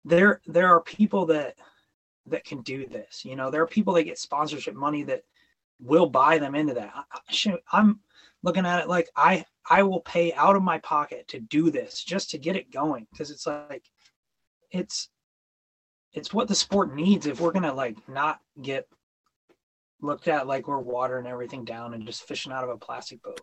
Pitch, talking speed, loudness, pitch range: 170 Hz, 200 wpm, -25 LUFS, 145-205 Hz